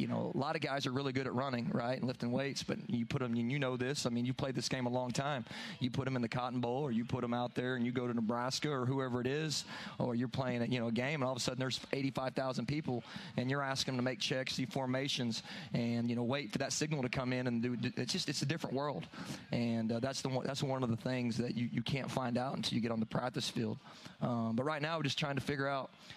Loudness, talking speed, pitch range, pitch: -37 LUFS, 300 wpm, 120-140 Hz, 130 Hz